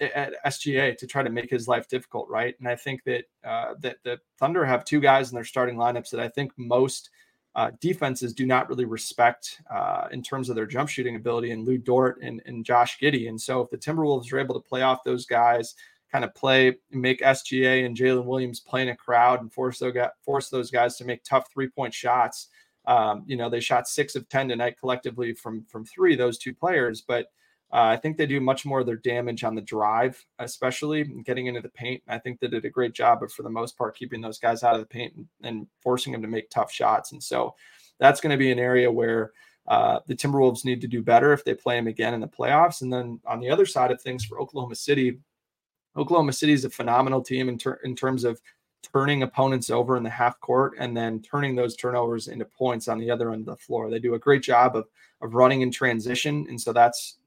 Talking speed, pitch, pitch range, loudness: 240 wpm, 125 Hz, 120-135 Hz, -25 LUFS